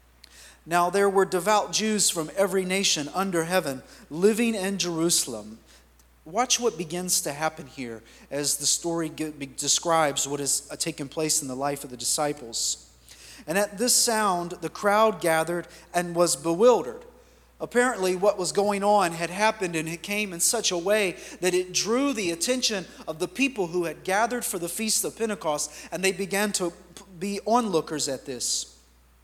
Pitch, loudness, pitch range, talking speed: 175 Hz, -25 LUFS, 150-200 Hz, 170 wpm